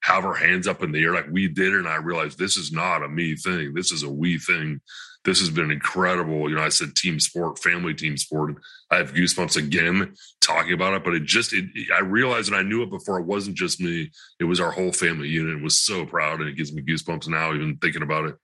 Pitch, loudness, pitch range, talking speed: 85 Hz, -22 LUFS, 75-95 Hz, 255 wpm